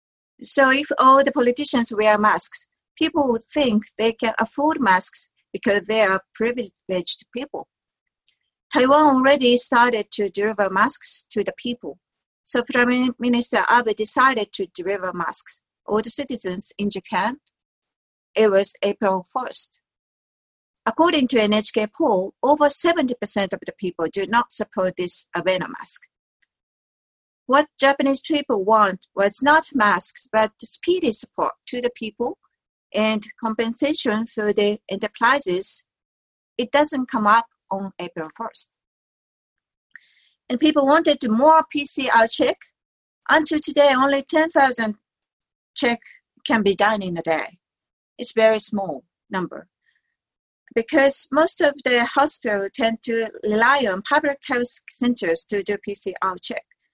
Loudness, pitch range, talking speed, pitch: -20 LUFS, 205-275 Hz, 135 wpm, 230 Hz